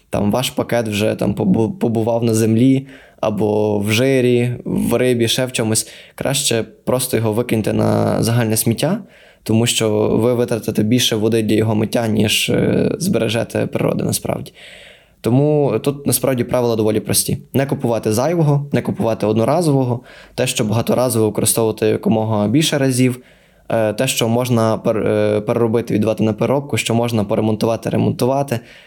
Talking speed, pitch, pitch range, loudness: 135 wpm, 115 Hz, 110-125 Hz, -17 LUFS